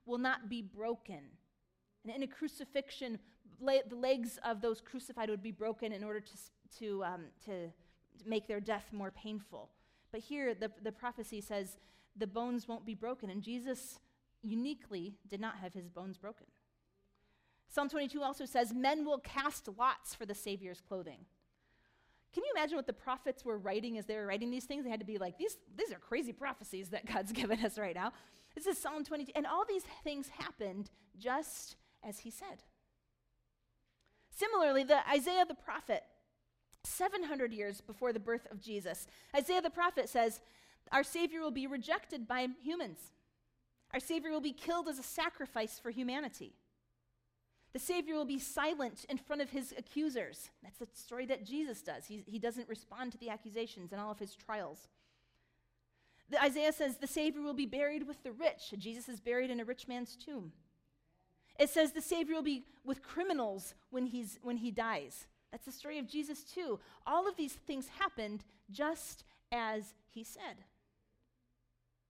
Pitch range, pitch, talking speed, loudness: 210-285 Hz, 240 Hz, 175 wpm, -39 LUFS